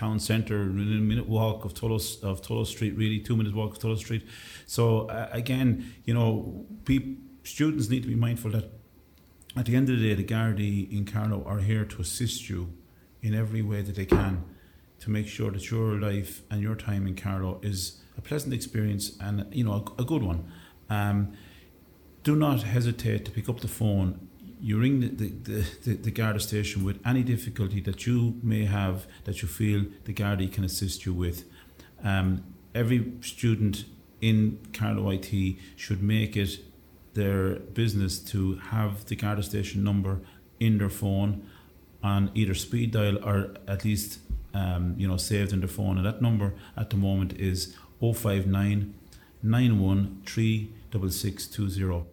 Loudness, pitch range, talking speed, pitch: -29 LUFS, 95-110 Hz, 180 wpm, 105 Hz